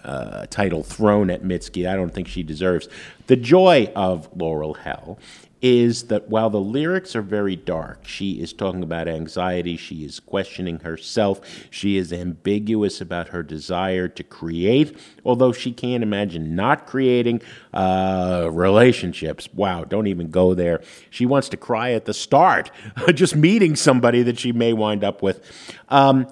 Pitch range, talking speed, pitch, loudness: 90-120 Hz, 160 wpm, 100 Hz, -20 LUFS